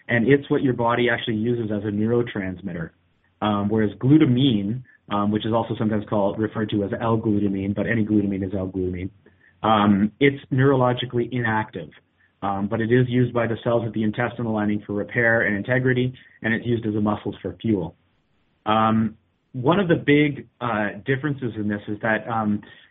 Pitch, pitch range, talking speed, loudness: 110 Hz, 105-120 Hz, 190 wpm, -22 LUFS